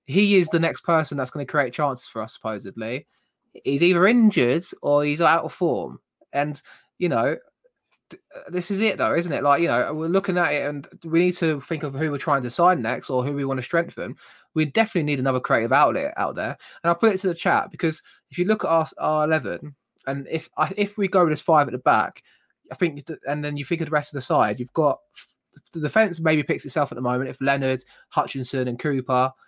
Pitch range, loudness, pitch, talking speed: 135-175 Hz, -23 LUFS, 155 Hz, 235 wpm